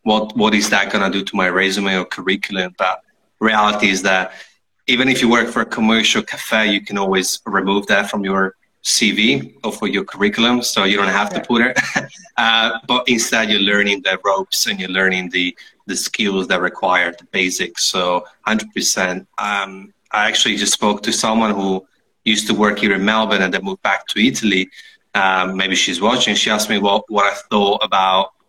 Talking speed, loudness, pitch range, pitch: 200 wpm, -16 LUFS, 95-110 Hz, 100 Hz